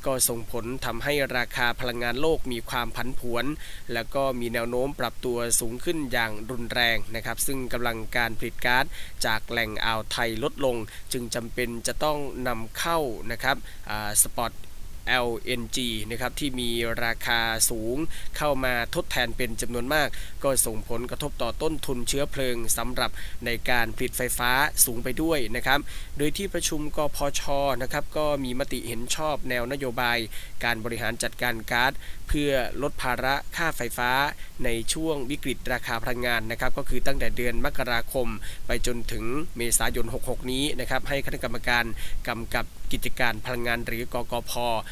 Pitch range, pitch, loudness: 115-135 Hz, 120 Hz, -27 LUFS